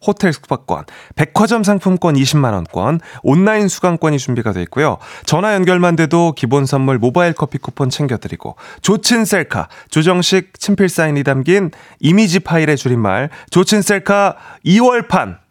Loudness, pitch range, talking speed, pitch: -14 LUFS, 135-190 Hz, 310 characters per minute, 165 Hz